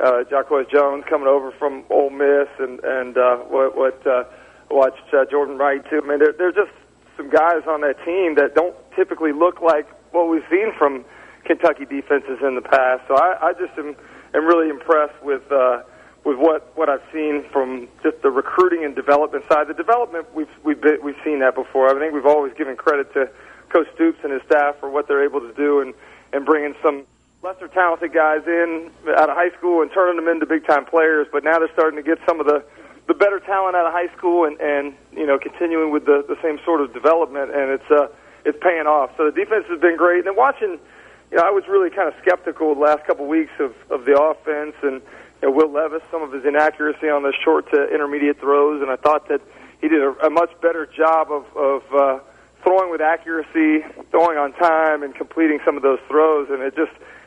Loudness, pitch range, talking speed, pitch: -18 LUFS, 140-170 Hz, 225 wpm, 155 Hz